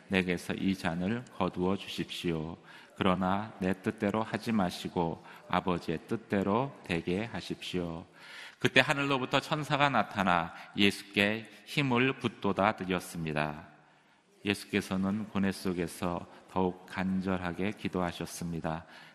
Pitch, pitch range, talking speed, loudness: 95 Hz, 90-105 Hz, 275 characters per minute, -32 LUFS